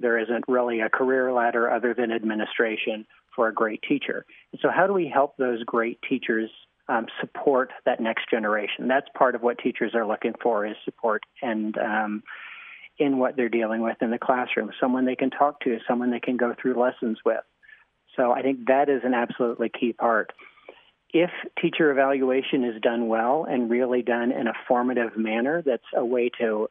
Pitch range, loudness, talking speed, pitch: 115-130 Hz, -25 LUFS, 190 wpm, 120 Hz